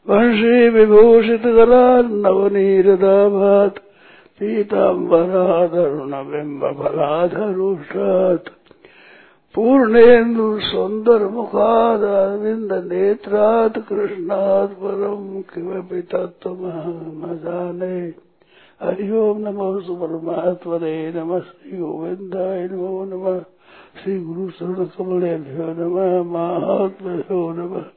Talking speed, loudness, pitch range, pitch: 30 wpm, -17 LUFS, 175-210 Hz, 190 Hz